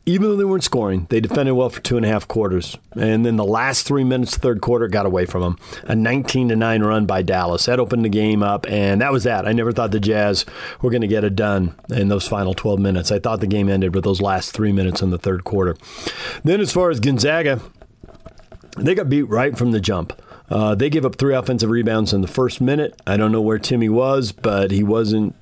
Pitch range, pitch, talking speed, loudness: 100-125 Hz, 110 Hz, 250 wpm, -19 LUFS